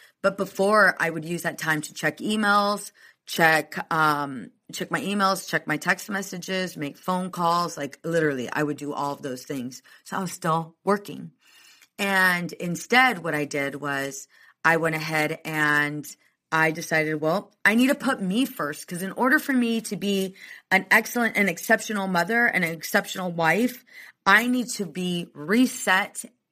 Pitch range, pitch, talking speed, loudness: 155-205 Hz, 180 Hz, 170 wpm, -24 LUFS